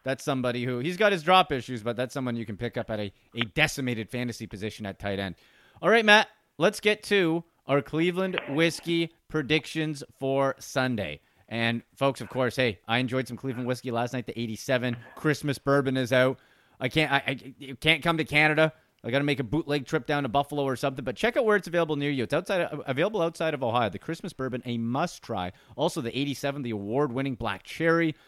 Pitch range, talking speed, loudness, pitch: 120-155 Hz, 215 wpm, -27 LUFS, 135 Hz